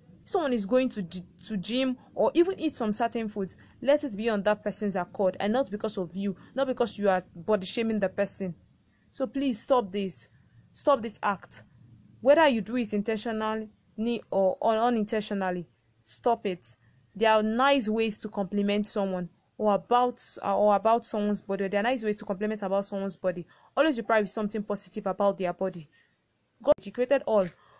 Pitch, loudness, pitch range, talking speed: 210 Hz, -28 LUFS, 190-235 Hz, 180 wpm